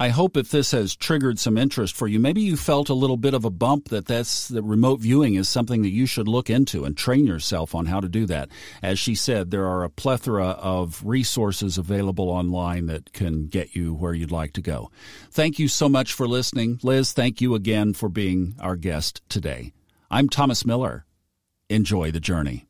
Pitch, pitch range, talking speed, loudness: 105 Hz, 90-125 Hz, 210 wpm, -23 LUFS